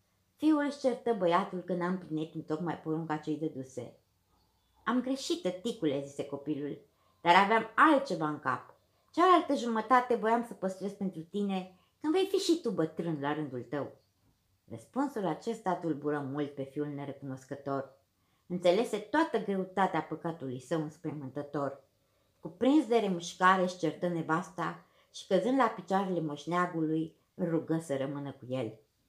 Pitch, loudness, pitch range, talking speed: 165 Hz, -32 LUFS, 140-200 Hz, 140 wpm